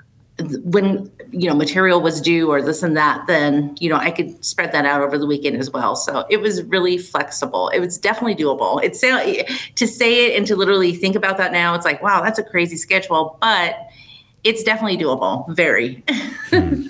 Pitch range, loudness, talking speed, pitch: 155-215 Hz, -17 LUFS, 195 wpm, 175 Hz